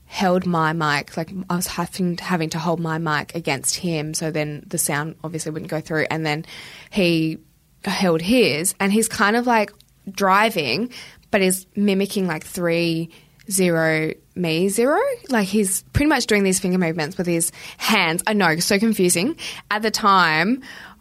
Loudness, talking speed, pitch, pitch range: -20 LUFS, 175 wpm, 180 Hz, 160-205 Hz